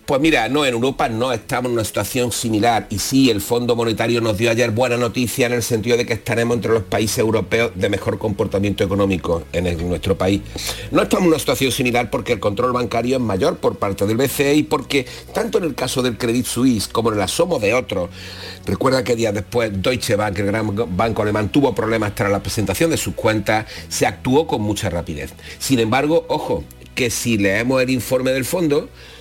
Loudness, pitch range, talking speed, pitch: -19 LUFS, 100-125 Hz, 215 wpm, 115 Hz